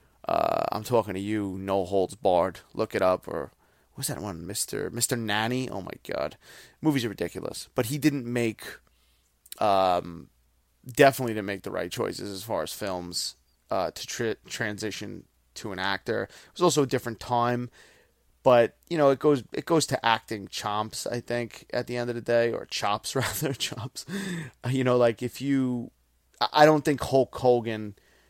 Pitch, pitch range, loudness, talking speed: 120 Hz, 100-130 Hz, -27 LUFS, 180 wpm